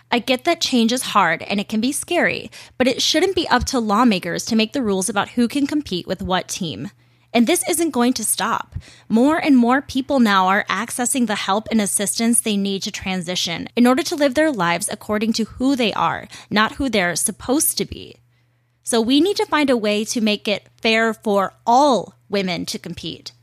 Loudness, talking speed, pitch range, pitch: -19 LUFS, 215 wpm, 195-260 Hz, 225 Hz